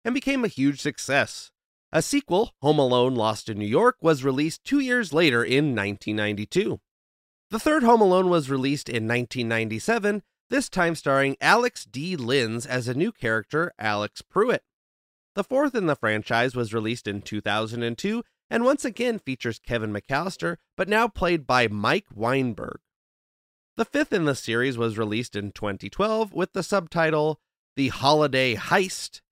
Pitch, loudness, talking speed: 135 Hz, -24 LUFS, 155 wpm